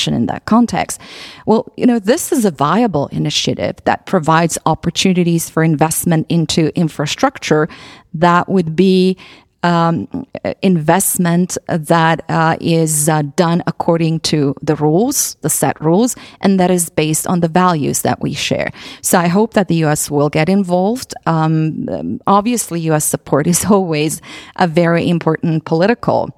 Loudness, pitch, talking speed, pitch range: -14 LUFS, 170 Hz, 145 wpm, 160-190 Hz